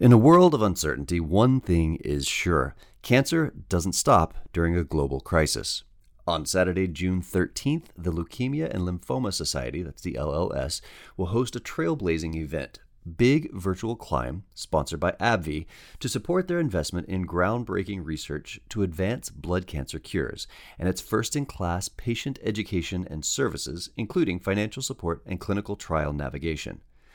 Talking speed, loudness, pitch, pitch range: 145 wpm, -26 LUFS, 90 Hz, 85-115 Hz